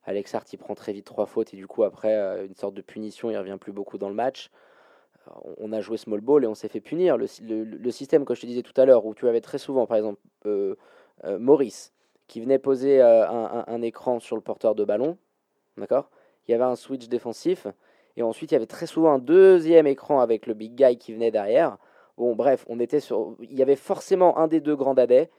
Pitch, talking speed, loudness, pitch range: 125 Hz, 250 wpm, -23 LUFS, 110-160 Hz